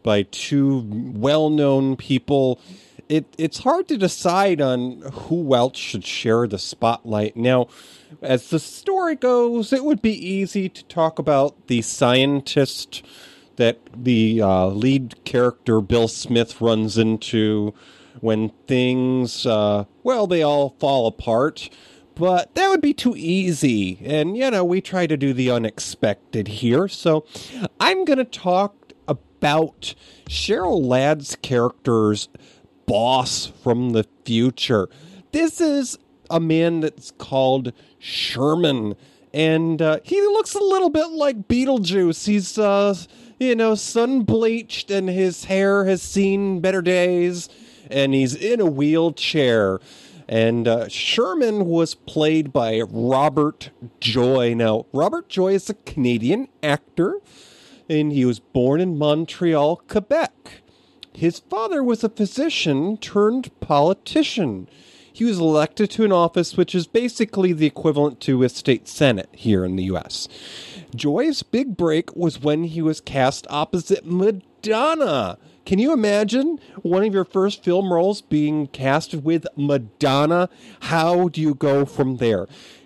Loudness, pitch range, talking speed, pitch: -20 LUFS, 125-195 Hz, 135 wpm, 155 Hz